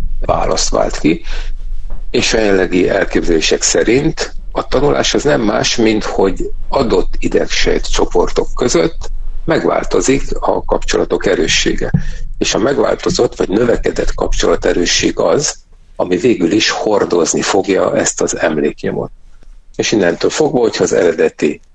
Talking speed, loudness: 125 wpm, -14 LUFS